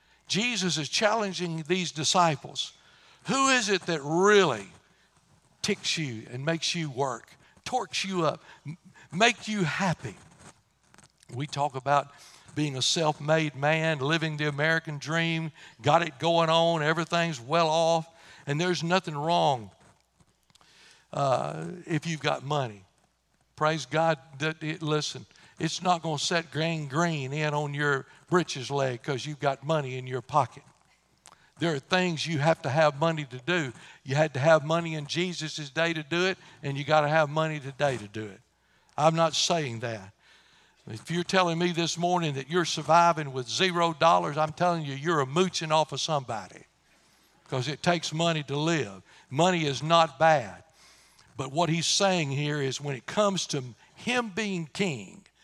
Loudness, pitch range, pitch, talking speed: -27 LUFS, 145-170 Hz, 160 Hz, 165 wpm